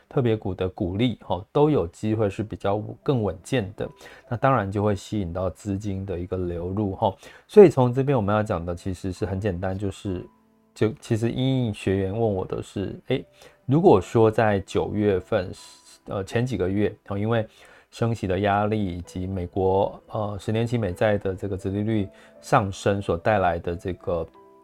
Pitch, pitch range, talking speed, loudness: 100 Hz, 95-110 Hz, 265 characters per minute, -24 LUFS